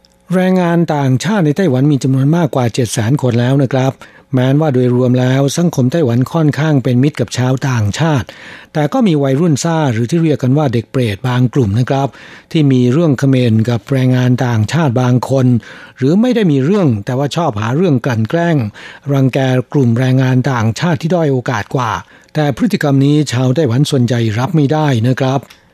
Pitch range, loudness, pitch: 125-150 Hz, -13 LUFS, 135 Hz